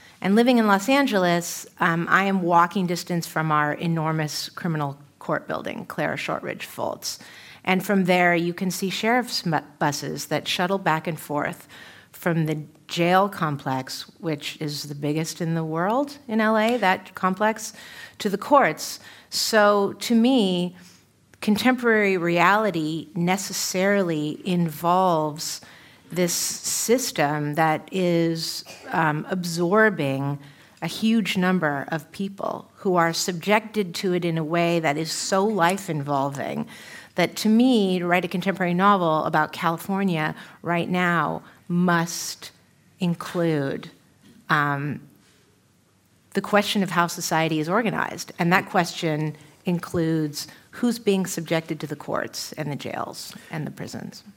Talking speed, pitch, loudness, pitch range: 130 wpm, 175 Hz, -23 LUFS, 155-195 Hz